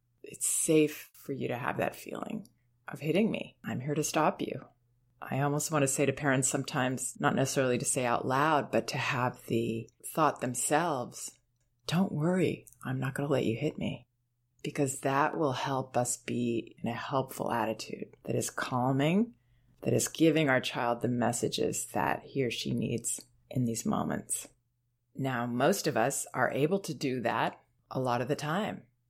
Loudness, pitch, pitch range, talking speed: -31 LUFS, 130 Hz, 120-150 Hz, 180 wpm